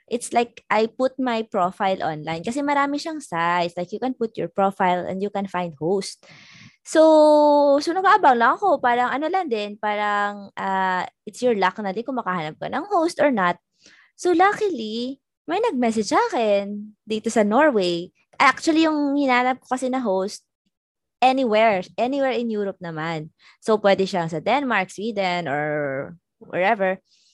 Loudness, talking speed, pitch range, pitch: -21 LUFS, 160 wpm, 190-260 Hz, 220 Hz